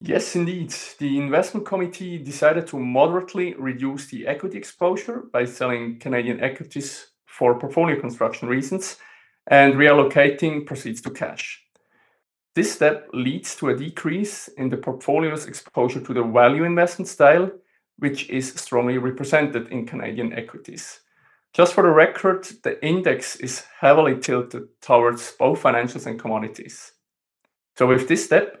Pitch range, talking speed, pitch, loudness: 130-175 Hz, 135 wpm, 140 Hz, -21 LUFS